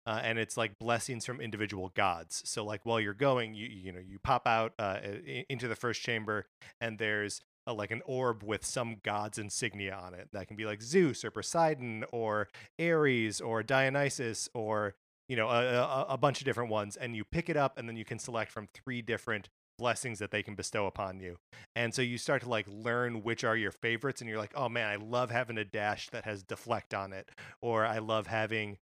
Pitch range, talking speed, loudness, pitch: 105-120 Hz, 220 wpm, -34 LUFS, 110 Hz